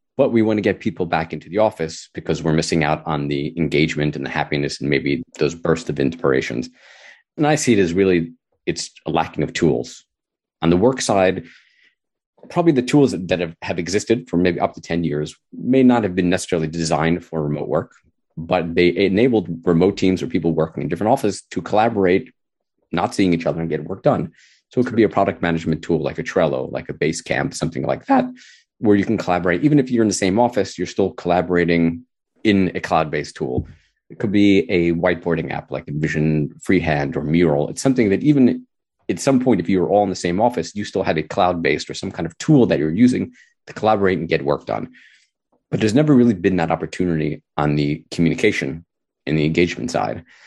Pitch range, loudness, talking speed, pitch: 80-105 Hz, -19 LUFS, 215 wpm, 90 Hz